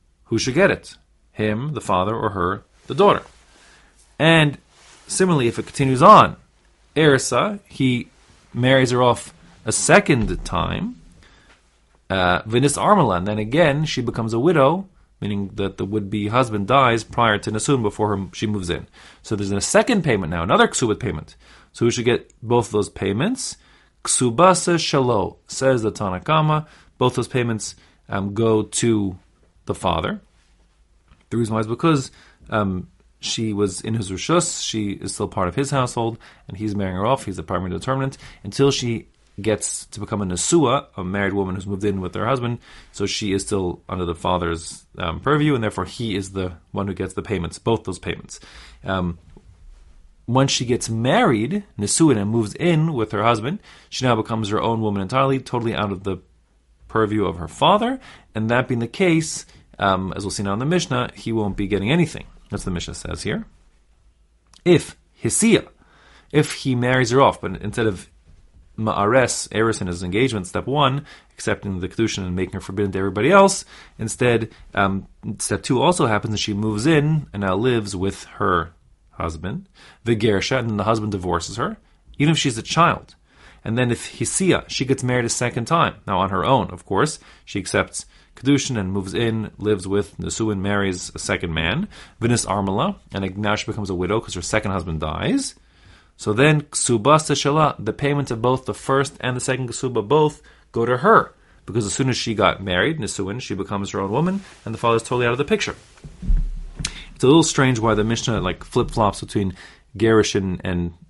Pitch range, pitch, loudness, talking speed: 95-130 Hz, 110 Hz, -20 LUFS, 185 wpm